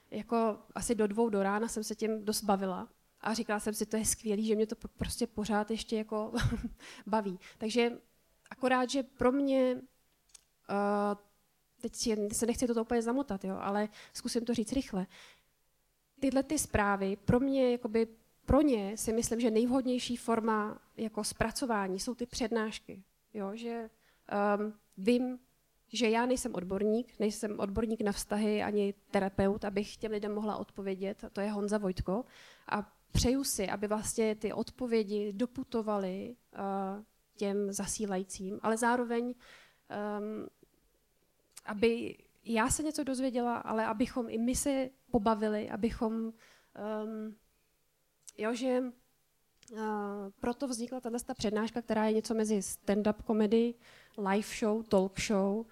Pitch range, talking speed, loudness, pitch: 205-235 Hz, 140 wpm, -33 LUFS, 220 Hz